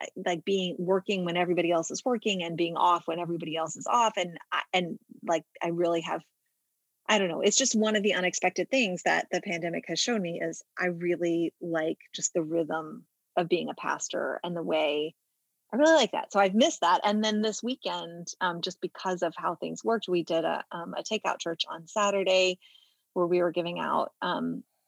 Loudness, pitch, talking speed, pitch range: -28 LUFS, 175 Hz, 210 wpm, 170-205 Hz